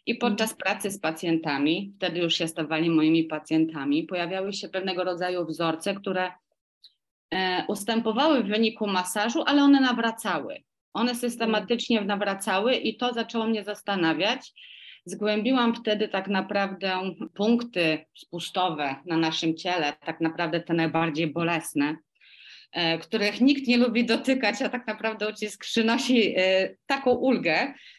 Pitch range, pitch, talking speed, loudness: 170-230 Hz, 200 Hz, 130 wpm, -26 LUFS